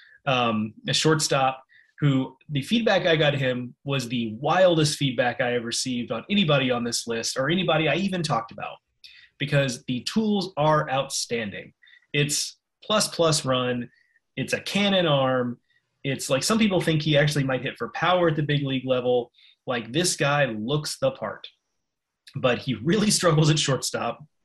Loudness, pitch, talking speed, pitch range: -24 LUFS, 140 Hz, 175 wpm, 125-165 Hz